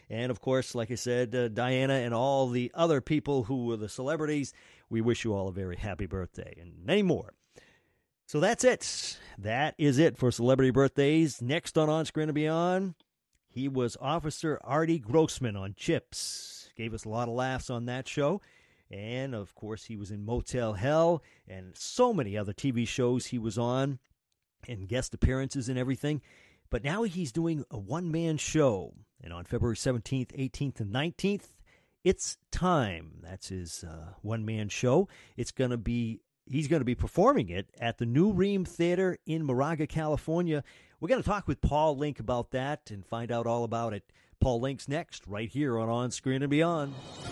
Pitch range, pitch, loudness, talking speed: 115-155 Hz, 130 Hz, -30 LUFS, 185 wpm